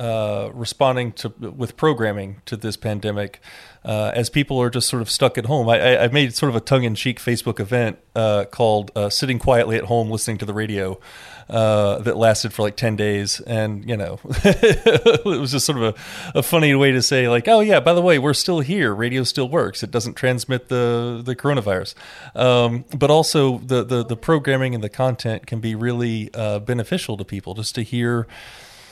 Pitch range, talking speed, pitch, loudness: 110-130 Hz, 210 wpm, 120 Hz, -19 LUFS